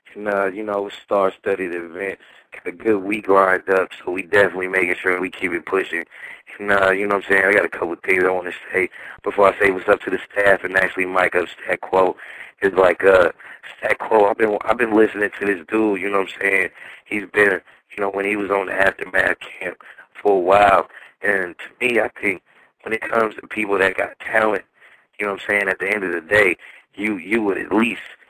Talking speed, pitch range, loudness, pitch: 240 wpm, 95-100 Hz, -19 LUFS, 100 Hz